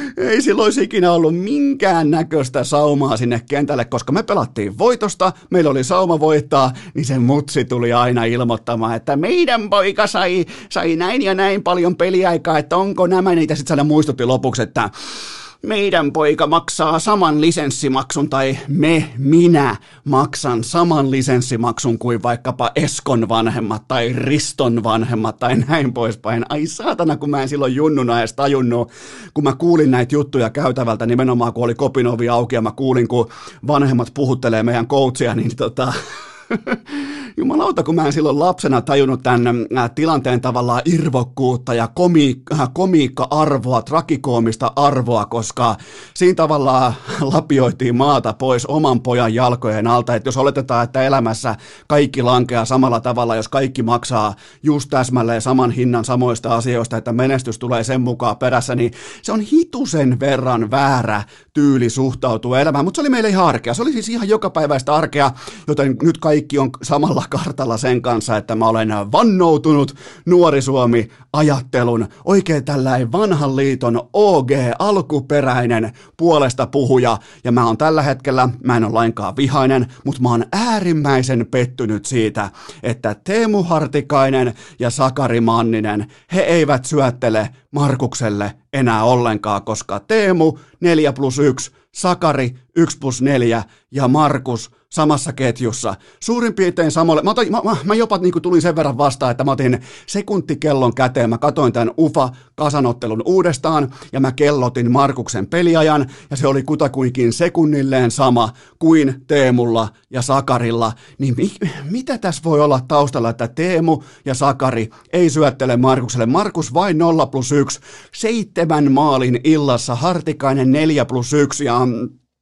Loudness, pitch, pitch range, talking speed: -16 LUFS, 135 Hz, 120-155 Hz, 145 wpm